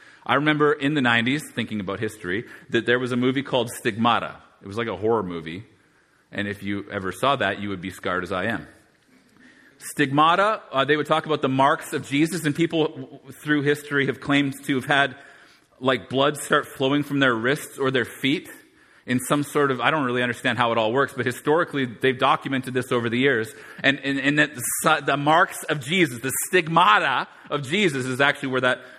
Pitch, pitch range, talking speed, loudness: 135 Hz, 120-145 Hz, 200 wpm, -22 LUFS